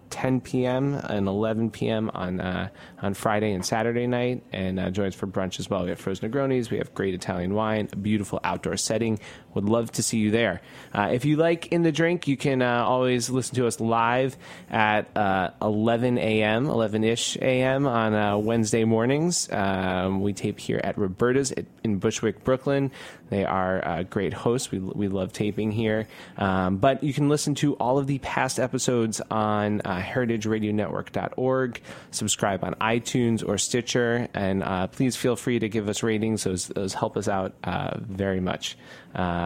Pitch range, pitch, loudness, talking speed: 100-125 Hz, 110 Hz, -25 LUFS, 185 wpm